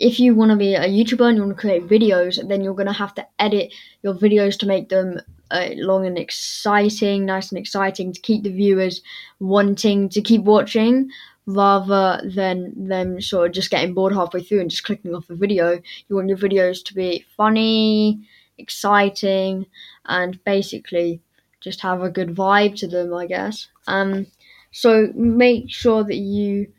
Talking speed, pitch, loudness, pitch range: 180 wpm, 195 Hz, -19 LUFS, 185-210 Hz